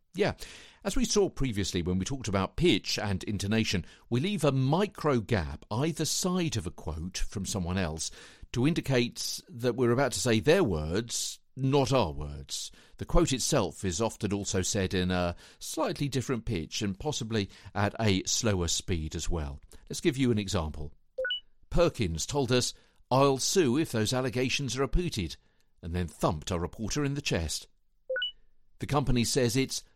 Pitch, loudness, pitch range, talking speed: 110 Hz, -30 LUFS, 90-135 Hz, 165 wpm